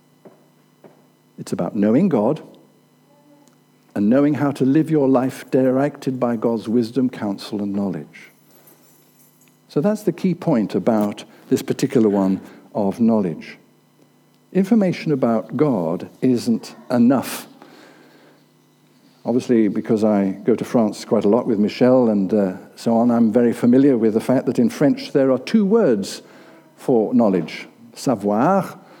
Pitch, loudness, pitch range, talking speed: 125 Hz, -19 LUFS, 110-140 Hz, 135 wpm